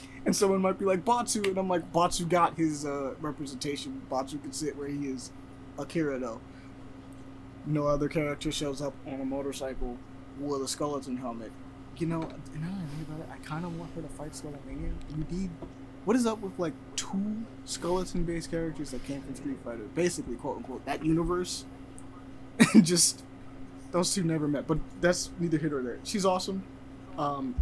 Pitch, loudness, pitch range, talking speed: 145 Hz, -31 LUFS, 135-165 Hz, 180 wpm